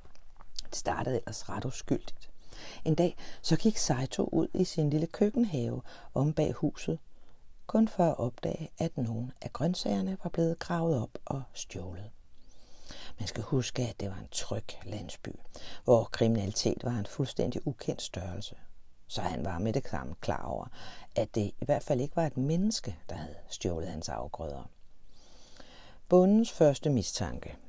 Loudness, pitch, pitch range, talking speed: -32 LUFS, 125 Hz, 105-165 Hz, 160 wpm